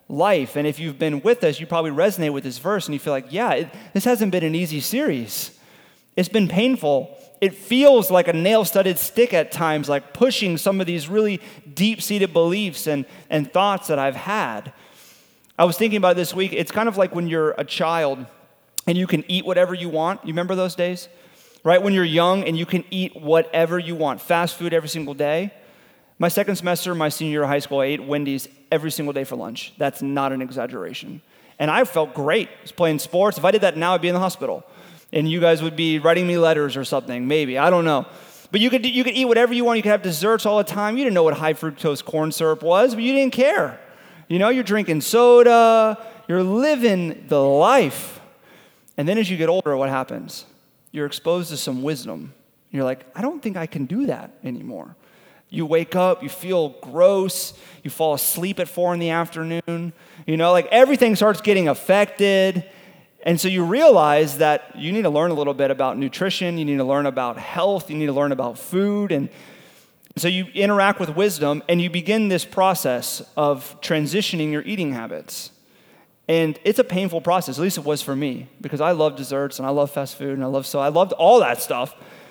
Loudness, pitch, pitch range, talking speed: -20 LUFS, 170 Hz, 150-195 Hz, 220 wpm